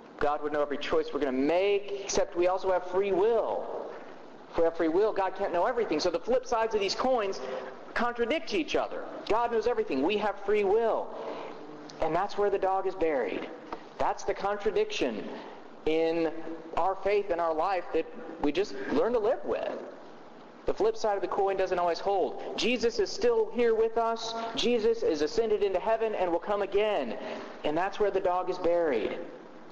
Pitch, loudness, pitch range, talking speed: 205 Hz, -29 LUFS, 180-280 Hz, 190 wpm